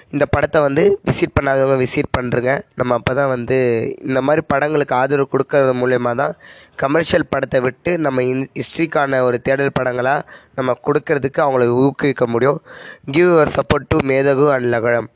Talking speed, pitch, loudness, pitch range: 155 wpm, 135 Hz, -17 LUFS, 125-145 Hz